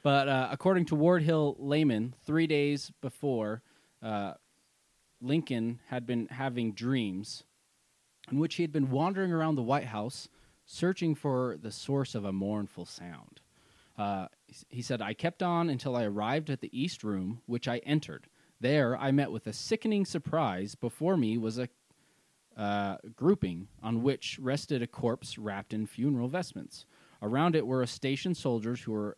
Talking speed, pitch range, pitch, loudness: 165 wpm, 110-150 Hz, 130 Hz, -32 LUFS